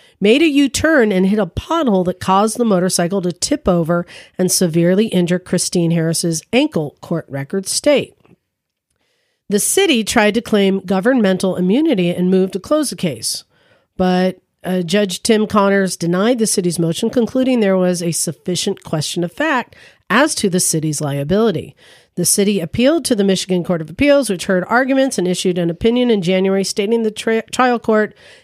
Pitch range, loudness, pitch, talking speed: 180-230 Hz, -16 LUFS, 195 Hz, 175 wpm